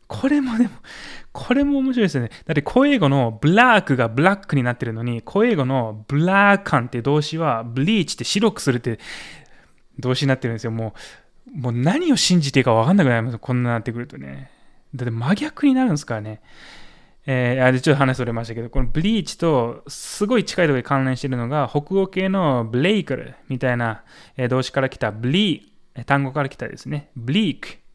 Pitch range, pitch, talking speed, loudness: 120-190 Hz, 135 Hz, 420 characters per minute, -20 LUFS